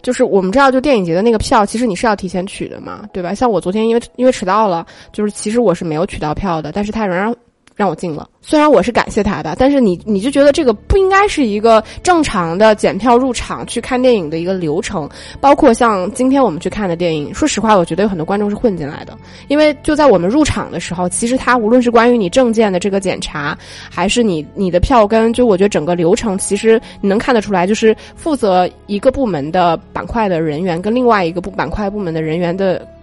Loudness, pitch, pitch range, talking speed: -14 LUFS, 210 Hz, 180-245 Hz, 370 characters per minute